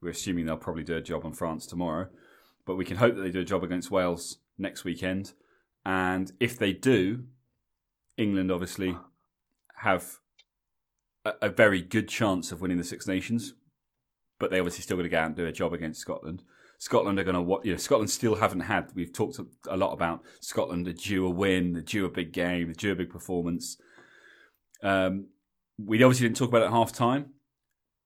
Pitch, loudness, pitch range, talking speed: 95 Hz, -29 LUFS, 90-105 Hz, 200 wpm